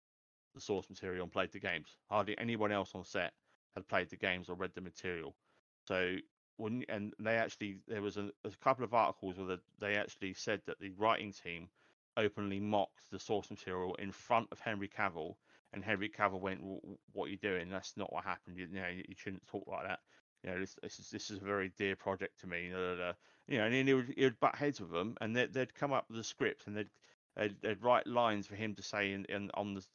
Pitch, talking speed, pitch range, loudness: 100 Hz, 240 wpm, 95-105 Hz, -39 LUFS